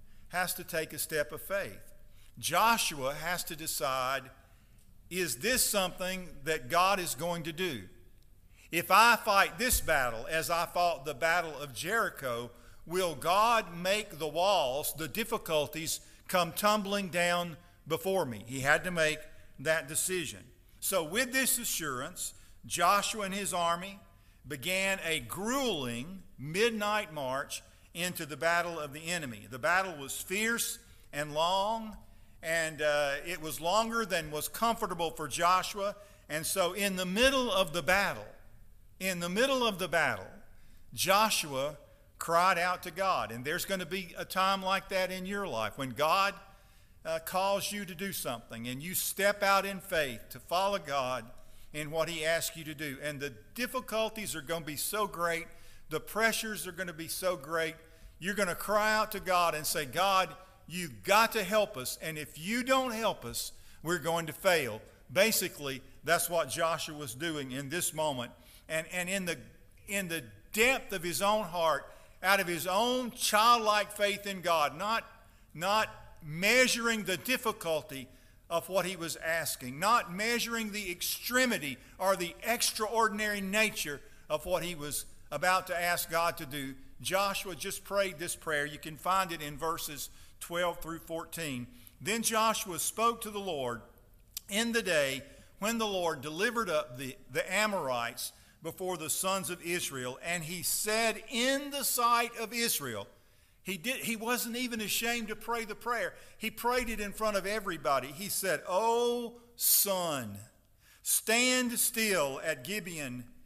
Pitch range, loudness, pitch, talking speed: 150-205 Hz, -31 LUFS, 175 Hz, 160 wpm